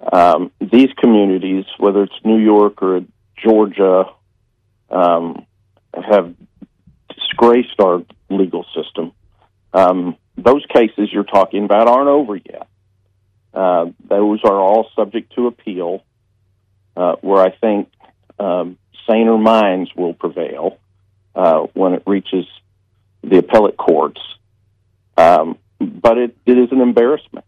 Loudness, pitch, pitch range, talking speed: -14 LUFS, 100 Hz, 95-110 Hz, 120 wpm